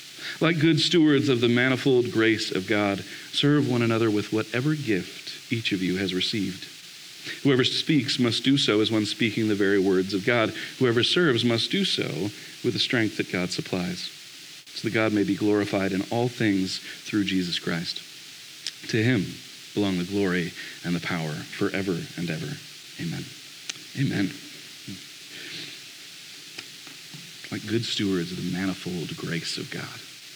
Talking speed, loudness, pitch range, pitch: 155 wpm, -25 LUFS, 100-130 Hz, 110 Hz